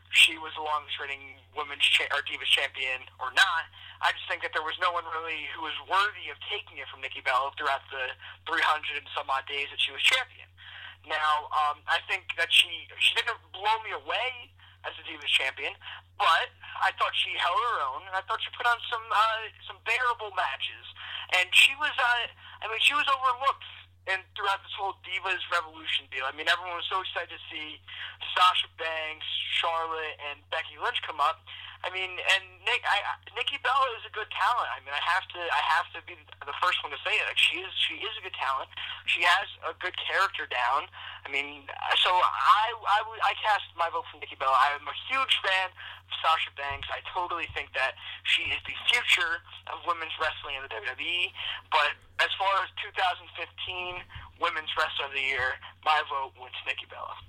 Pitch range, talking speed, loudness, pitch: 145-220 Hz, 200 wpm, -27 LUFS, 175 Hz